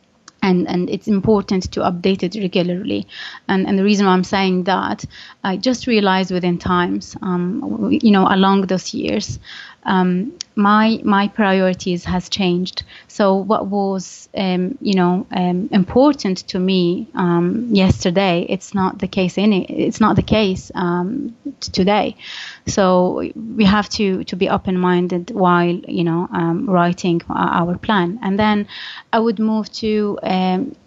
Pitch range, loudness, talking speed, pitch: 180-210 Hz, -17 LUFS, 155 wpm, 190 Hz